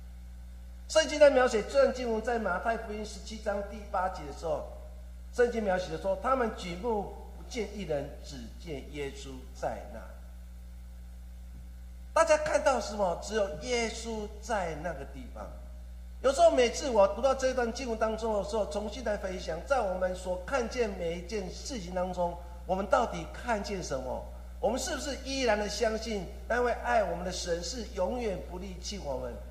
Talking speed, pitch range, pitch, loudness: 255 characters per minute, 140-235 Hz, 200 Hz, -31 LUFS